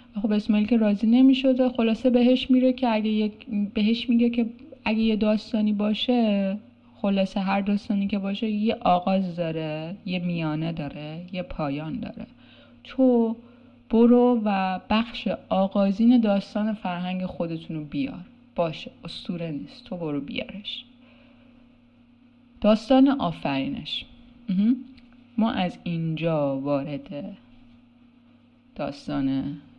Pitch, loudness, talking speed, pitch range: 215 Hz, -24 LUFS, 110 wpm, 185-245 Hz